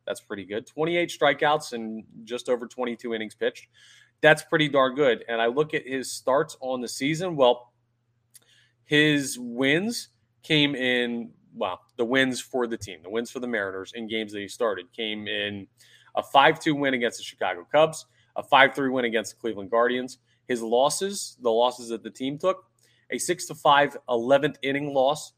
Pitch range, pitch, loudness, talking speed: 115-145 Hz, 125 Hz, -25 LUFS, 180 wpm